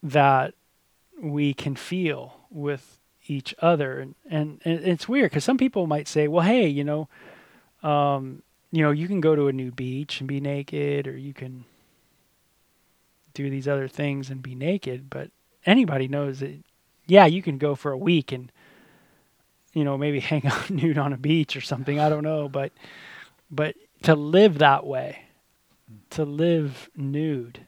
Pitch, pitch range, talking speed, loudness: 145 Hz, 135-160 Hz, 170 wpm, -24 LUFS